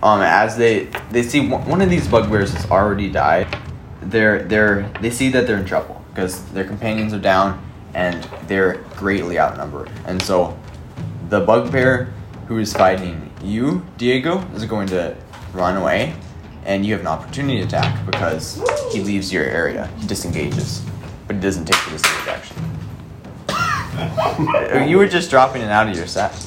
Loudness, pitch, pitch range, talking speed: -18 LUFS, 105 Hz, 95-125 Hz, 165 wpm